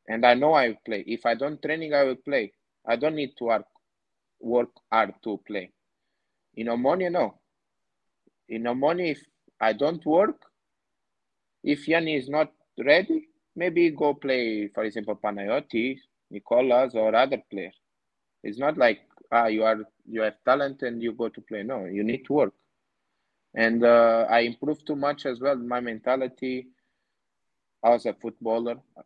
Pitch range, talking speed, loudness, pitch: 115-145 Hz, 165 wpm, -25 LUFS, 125 Hz